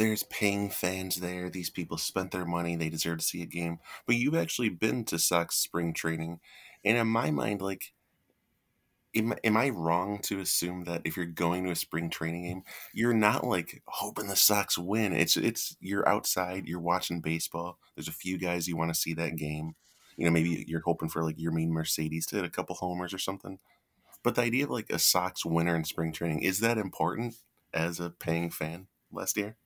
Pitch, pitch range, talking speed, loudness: 85 Hz, 80-95 Hz, 210 wpm, -30 LUFS